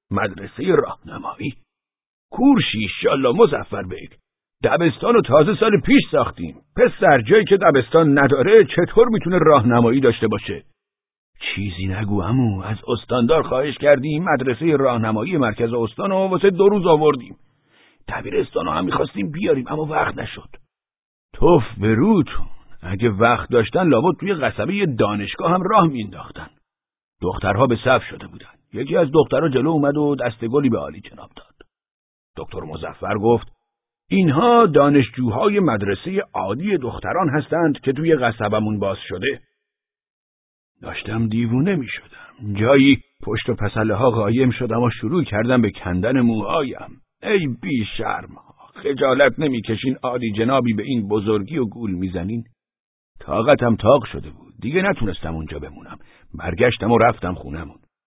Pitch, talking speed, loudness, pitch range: 120 Hz, 135 wpm, -18 LUFS, 110-155 Hz